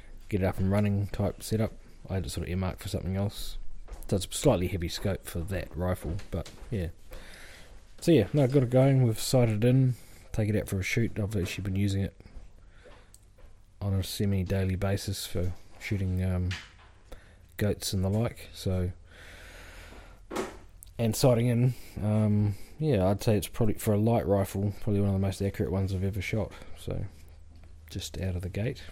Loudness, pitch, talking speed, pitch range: -29 LUFS, 100 Hz, 185 wpm, 90-105 Hz